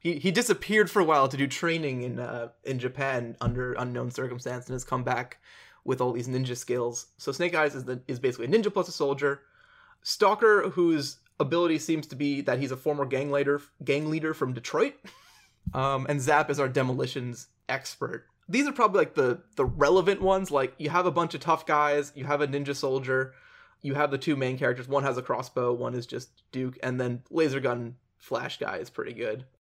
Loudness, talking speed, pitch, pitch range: -28 LUFS, 210 wpm, 140 Hz, 125-155 Hz